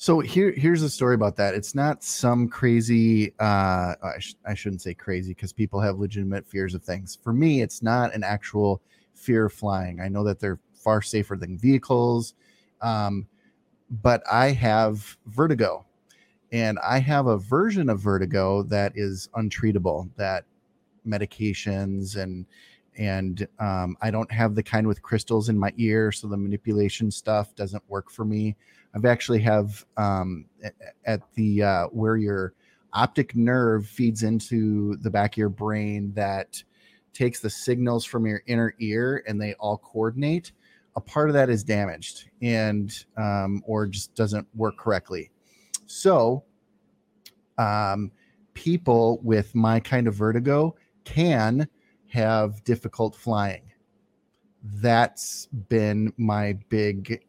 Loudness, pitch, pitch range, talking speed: -25 LUFS, 110 Hz, 100-115 Hz, 145 wpm